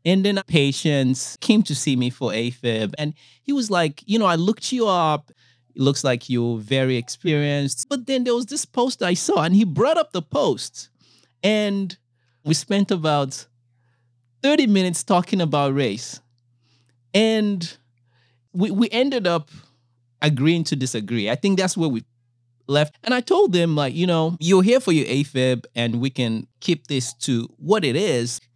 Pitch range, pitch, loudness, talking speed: 120-190 Hz, 145 Hz, -21 LUFS, 175 wpm